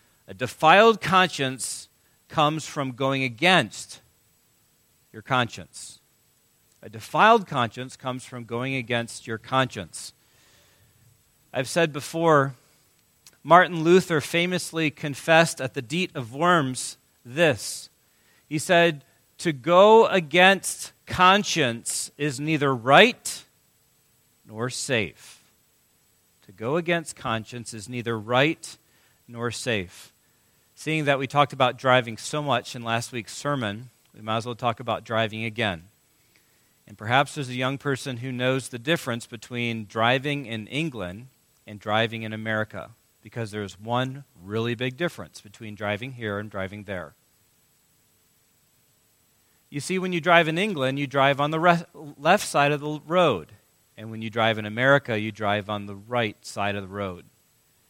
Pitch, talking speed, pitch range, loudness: 130 Hz, 140 wpm, 110-150 Hz, -23 LUFS